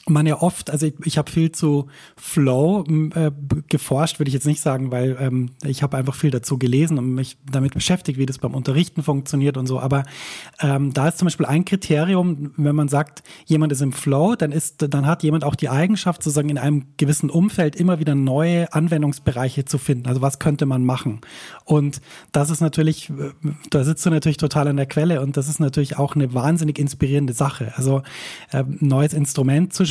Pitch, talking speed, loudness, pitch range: 150 Hz, 205 wpm, -20 LUFS, 140-155 Hz